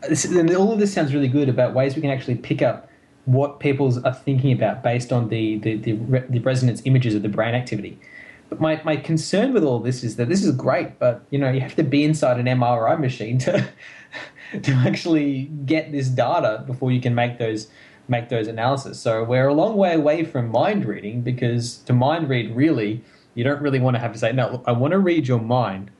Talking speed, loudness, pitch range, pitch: 230 wpm, -21 LUFS, 120-145 Hz, 130 Hz